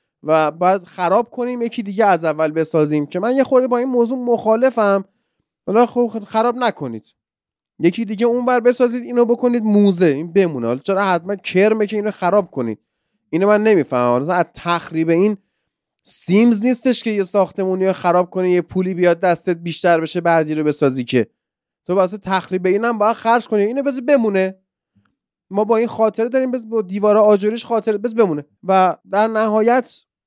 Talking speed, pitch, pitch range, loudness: 170 wpm, 200 Hz, 175-230 Hz, -17 LUFS